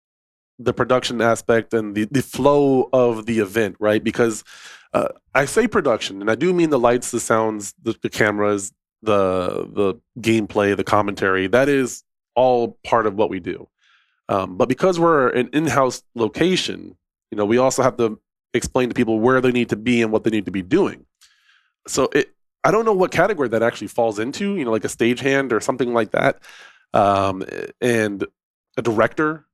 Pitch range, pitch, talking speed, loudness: 105-130 Hz, 115 Hz, 190 wpm, -19 LUFS